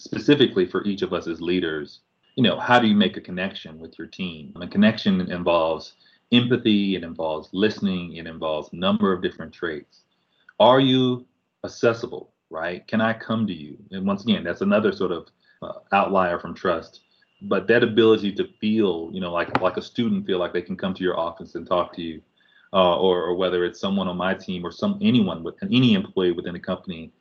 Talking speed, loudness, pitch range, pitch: 205 wpm, -22 LUFS, 85-125 Hz, 105 Hz